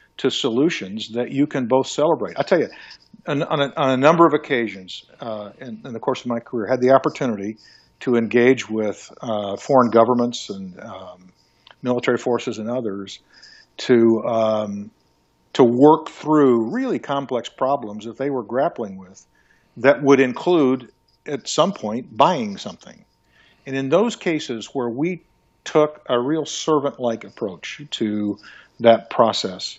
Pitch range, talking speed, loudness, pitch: 110-140 Hz, 155 wpm, -20 LUFS, 120 Hz